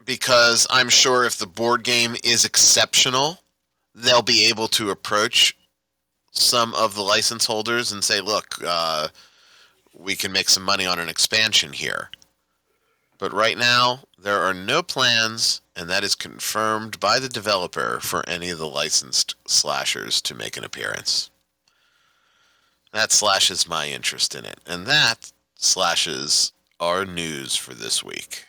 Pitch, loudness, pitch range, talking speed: 100 Hz, -19 LUFS, 75-120 Hz, 145 wpm